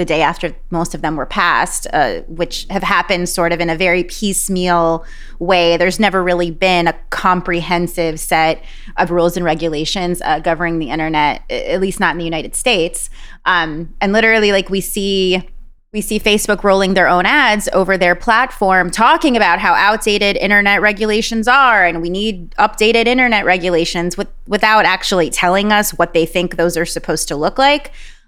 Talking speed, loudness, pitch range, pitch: 180 wpm, -14 LUFS, 170-205 Hz, 180 Hz